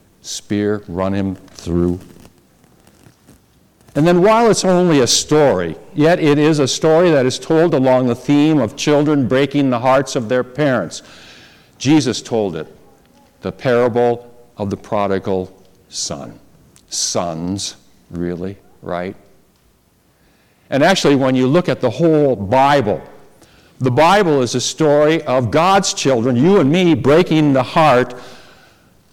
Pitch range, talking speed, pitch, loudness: 105-150 Hz, 135 wpm, 130 Hz, -15 LUFS